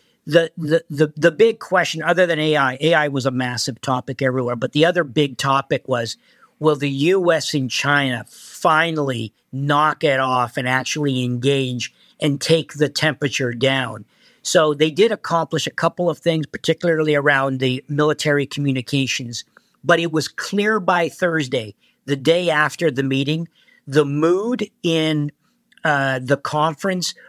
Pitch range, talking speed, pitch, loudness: 135-165 Hz, 150 wpm, 150 Hz, -19 LUFS